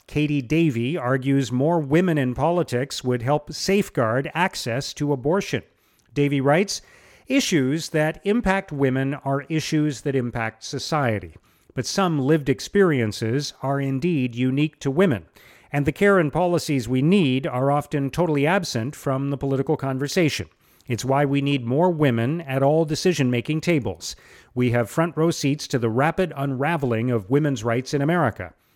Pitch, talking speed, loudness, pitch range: 140 Hz, 150 wpm, -22 LUFS, 130-160 Hz